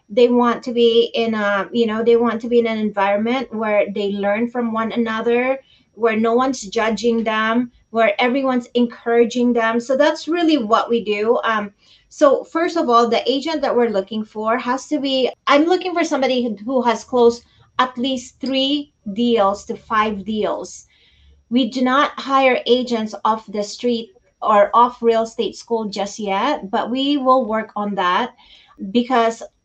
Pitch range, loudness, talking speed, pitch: 220-255 Hz, -18 LUFS, 175 wpm, 235 Hz